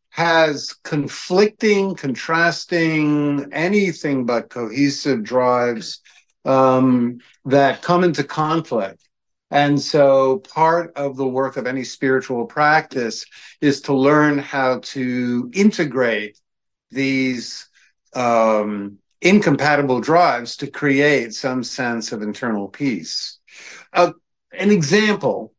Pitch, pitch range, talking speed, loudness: 140 Hz, 125-160 Hz, 100 wpm, -18 LUFS